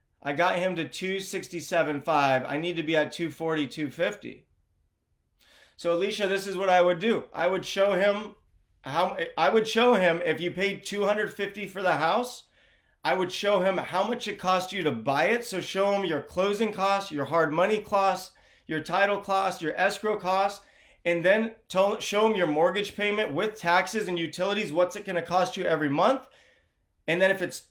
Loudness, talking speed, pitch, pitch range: -27 LUFS, 190 wpm, 190 Hz, 170-200 Hz